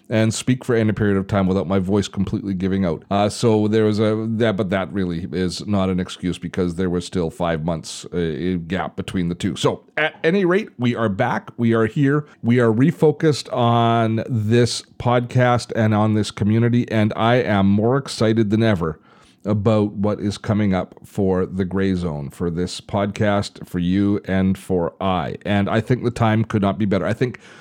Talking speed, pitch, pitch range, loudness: 200 wpm, 105 Hz, 95-115 Hz, -20 LUFS